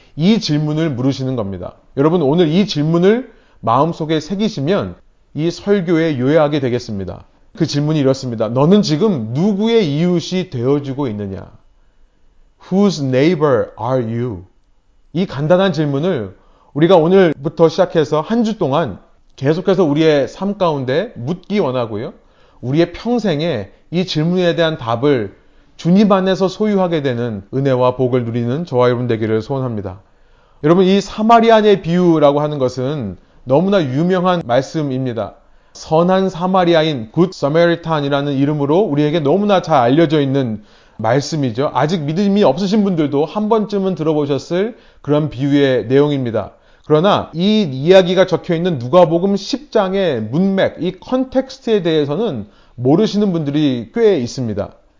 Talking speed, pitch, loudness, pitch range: 335 characters per minute, 155 Hz, -15 LUFS, 135-185 Hz